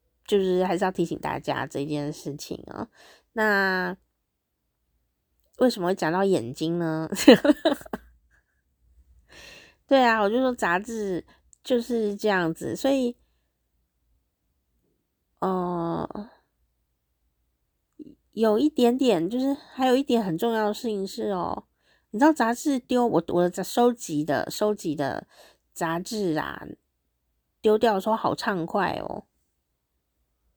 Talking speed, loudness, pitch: 175 characters per minute, -25 LUFS, 185 Hz